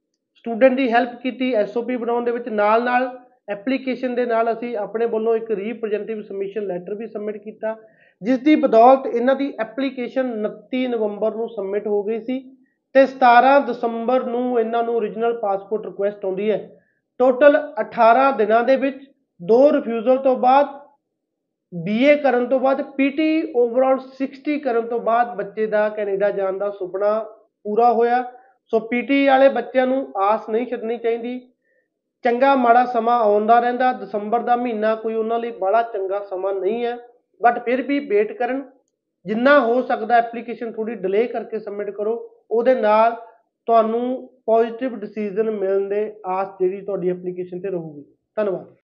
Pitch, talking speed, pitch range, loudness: 235 Hz, 155 wpm, 215-255 Hz, -20 LUFS